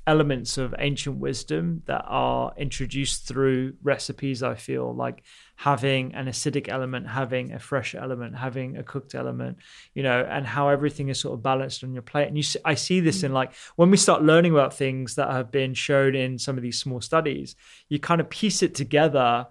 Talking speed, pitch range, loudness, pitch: 200 wpm, 125-145 Hz, -25 LUFS, 135 Hz